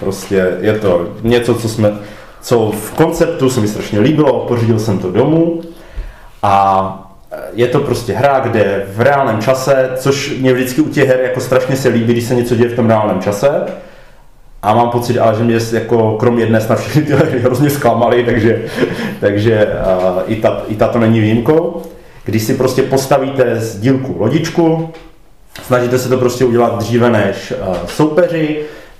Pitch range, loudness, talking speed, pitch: 110-135 Hz, -13 LUFS, 170 wpm, 120 Hz